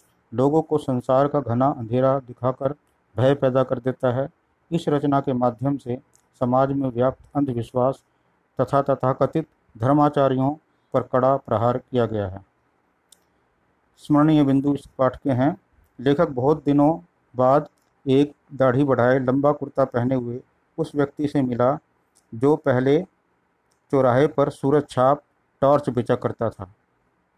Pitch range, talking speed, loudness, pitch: 125-145 Hz, 135 wpm, -22 LUFS, 135 Hz